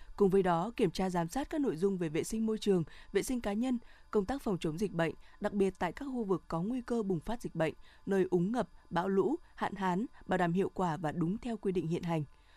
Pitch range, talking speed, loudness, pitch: 175-220 Hz, 265 wpm, -34 LUFS, 195 Hz